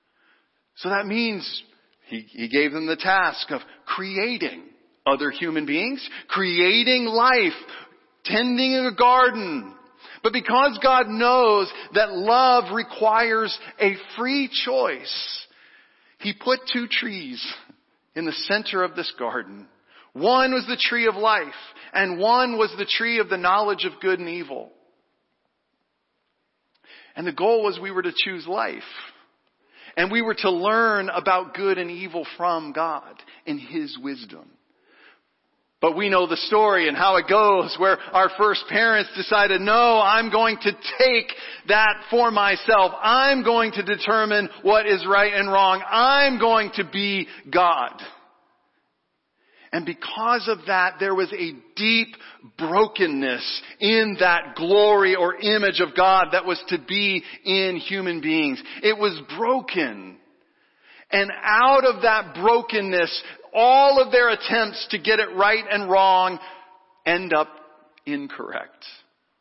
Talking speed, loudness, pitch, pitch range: 140 wpm, -20 LUFS, 210 Hz, 185-235 Hz